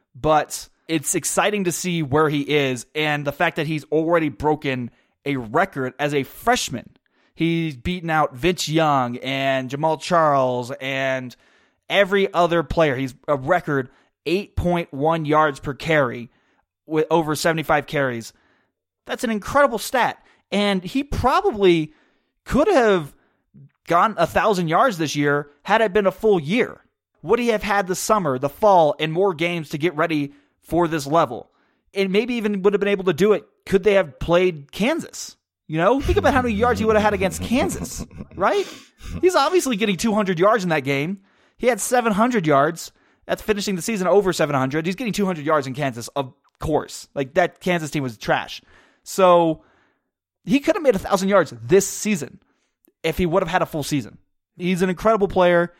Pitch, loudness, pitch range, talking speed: 170 Hz, -20 LUFS, 145-200 Hz, 175 wpm